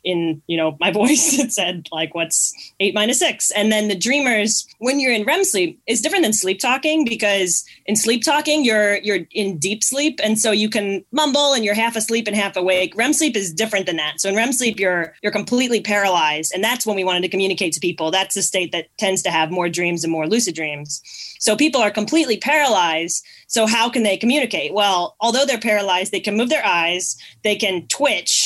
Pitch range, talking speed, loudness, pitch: 180-235 Hz, 220 wpm, -18 LUFS, 210 Hz